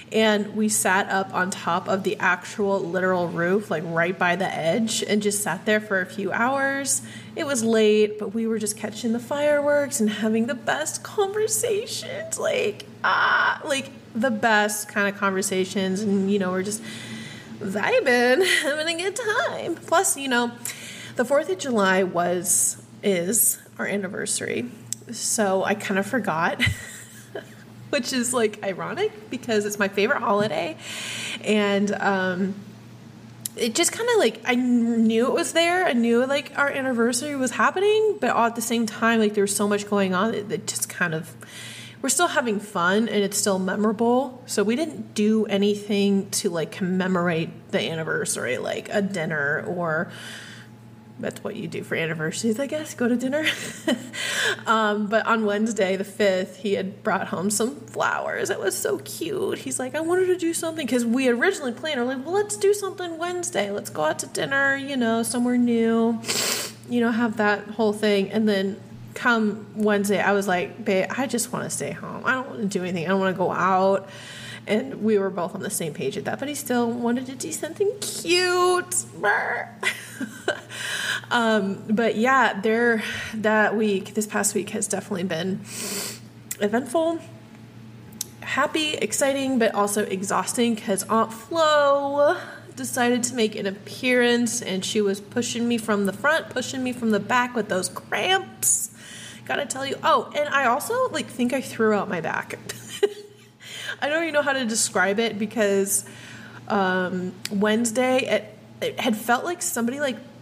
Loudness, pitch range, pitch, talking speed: -23 LUFS, 195-260 Hz, 215 Hz, 175 wpm